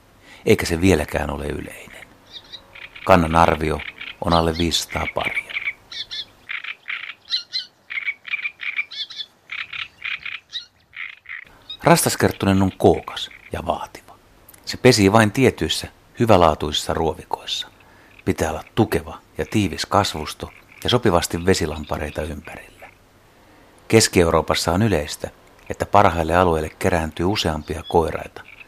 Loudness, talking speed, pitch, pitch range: -20 LUFS, 85 wpm, 90 Hz, 80-100 Hz